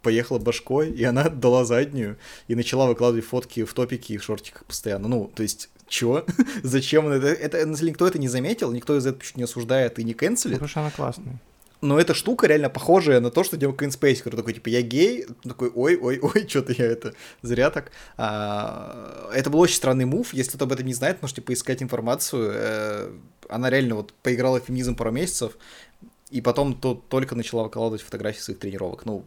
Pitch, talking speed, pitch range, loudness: 125 Hz, 190 wpm, 115-140 Hz, -24 LUFS